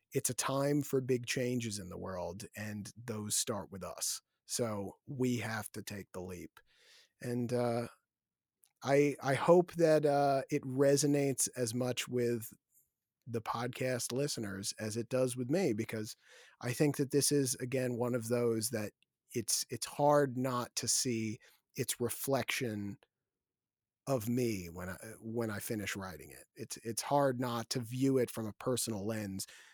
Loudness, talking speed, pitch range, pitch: -34 LUFS, 160 wpm, 110-135 Hz, 120 Hz